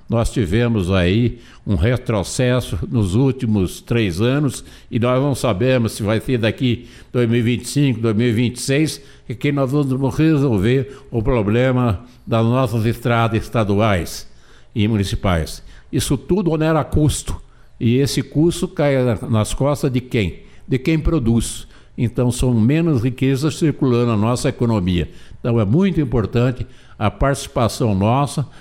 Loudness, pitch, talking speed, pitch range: -18 LUFS, 125 Hz, 130 wpm, 115-135 Hz